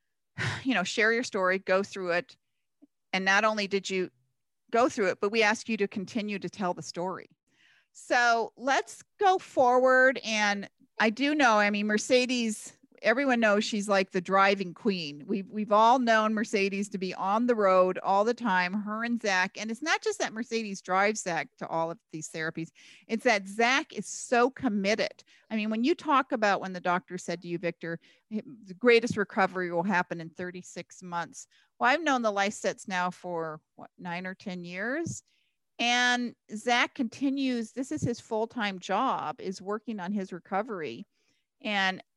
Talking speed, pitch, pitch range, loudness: 180 wpm, 210 Hz, 185-235 Hz, -28 LUFS